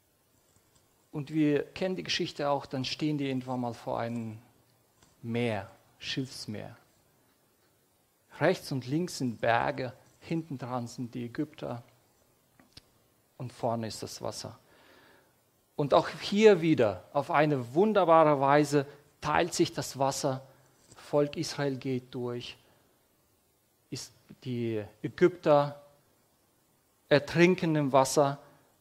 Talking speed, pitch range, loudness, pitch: 110 wpm, 120-150 Hz, -29 LUFS, 135 Hz